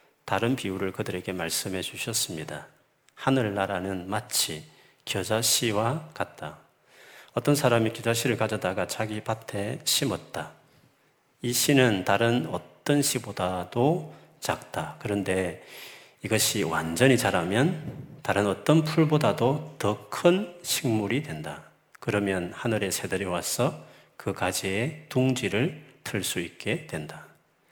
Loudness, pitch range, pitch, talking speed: -27 LUFS, 95-130 Hz, 110 Hz, 245 characters per minute